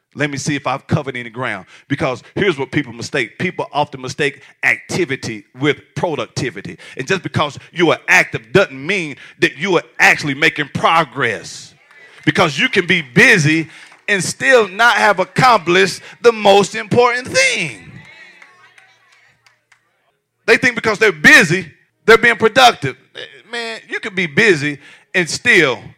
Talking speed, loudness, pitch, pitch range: 145 wpm, -14 LUFS, 185 Hz, 145-225 Hz